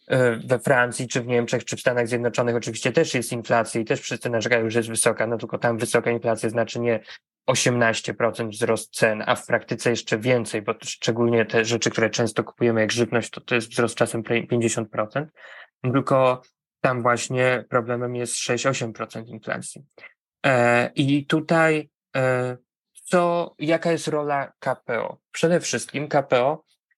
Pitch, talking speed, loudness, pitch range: 120 Hz, 145 wpm, -23 LUFS, 115-135 Hz